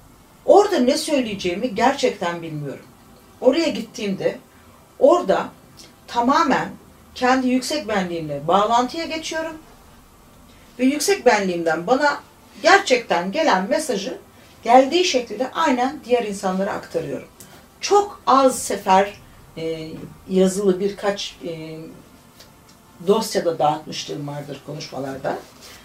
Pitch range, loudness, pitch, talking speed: 165-265 Hz, -20 LUFS, 210 Hz, 85 wpm